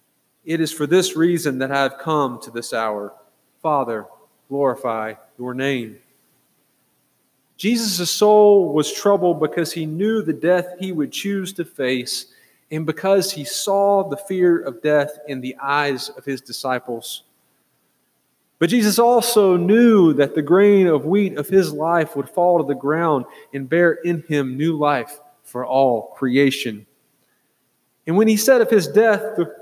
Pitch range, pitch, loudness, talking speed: 135-190 Hz, 155 Hz, -18 LUFS, 160 wpm